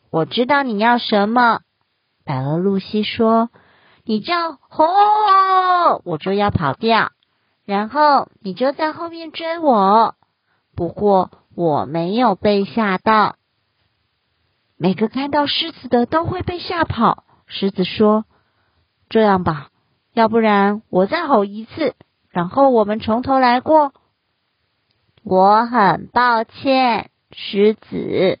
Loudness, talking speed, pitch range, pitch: -17 LUFS, 175 characters per minute, 185-260 Hz, 220 Hz